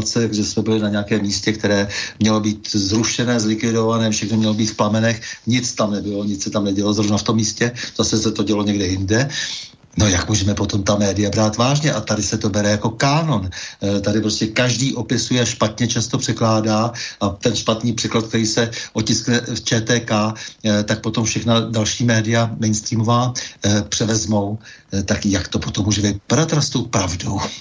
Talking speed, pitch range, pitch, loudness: 170 wpm, 105-115 Hz, 110 Hz, -19 LUFS